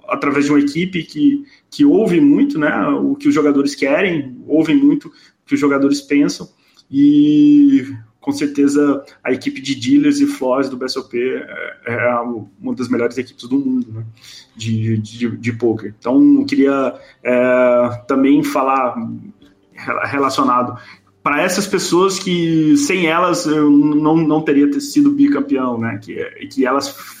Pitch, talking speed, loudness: 150 Hz, 155 wpm, -15 LUFS